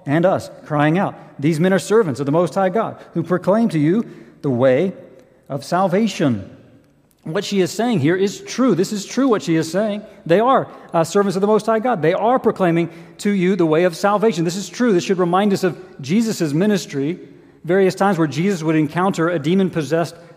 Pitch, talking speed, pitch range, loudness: 185 Hz, 210 wpm, 165-205 Hz, -18 LUFS